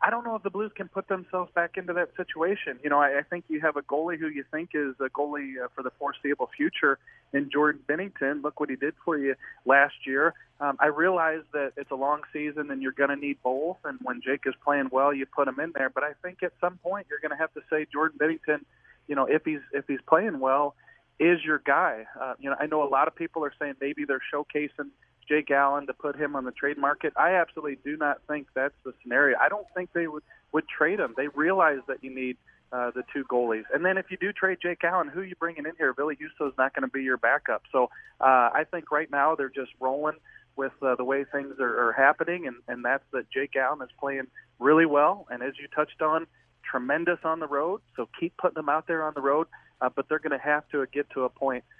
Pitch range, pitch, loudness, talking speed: 135-160 Hz, 145 Hz, -27 LUFS, 255 wpm